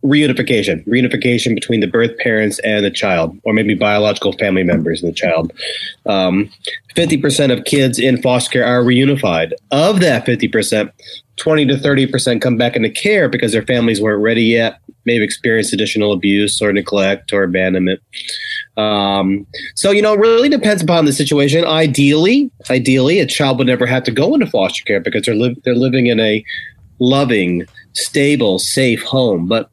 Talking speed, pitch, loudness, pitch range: 180 wpm, 125 Hz, -14 LUFS, 105-140 Hz